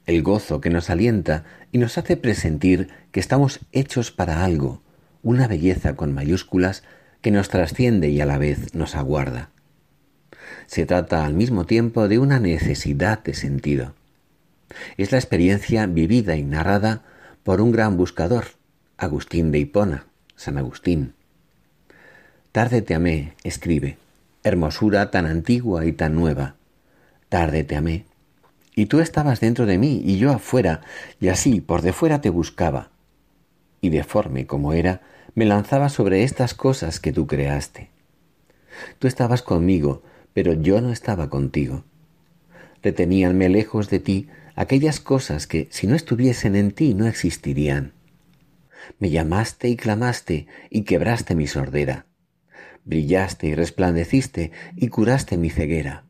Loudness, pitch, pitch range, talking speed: -21 LUFS, 95 Hz, 80-115 Hz, 140 wpm